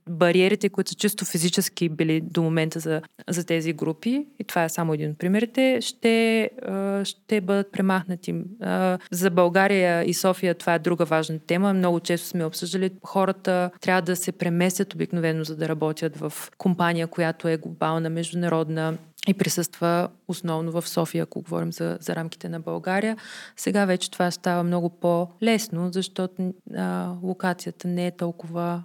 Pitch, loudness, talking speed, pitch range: 175 Hz, -25 LUFS, 155 wpm, 165-190 Hz